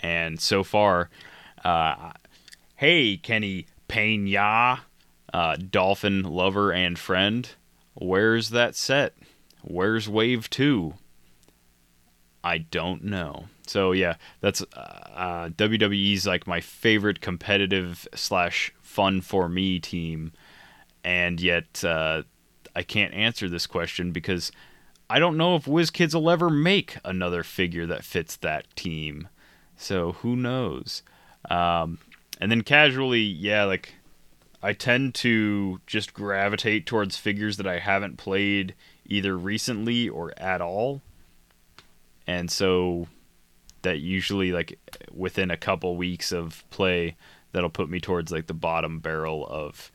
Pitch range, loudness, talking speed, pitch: 85-105 Hz, -25 LUFS, 125 wpm, 95 Hz